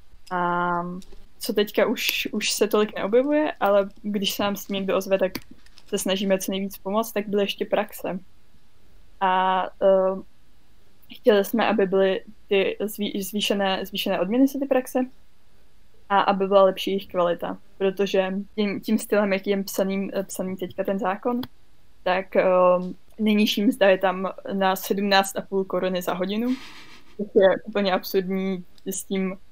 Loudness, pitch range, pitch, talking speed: -23 LUFS, 190-210 Hz, 195 Hz, 145 wpm